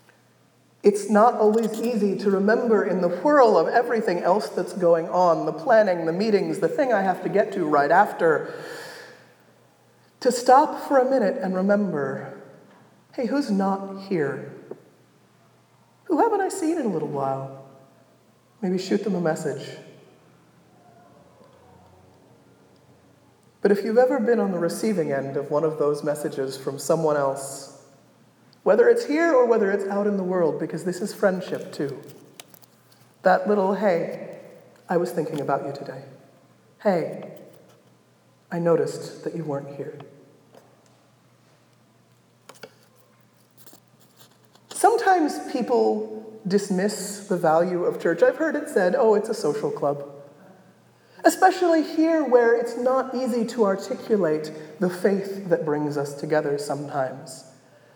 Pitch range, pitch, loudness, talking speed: 150-235 Hz, 195 Hz, -22 LUFS, 135 wpm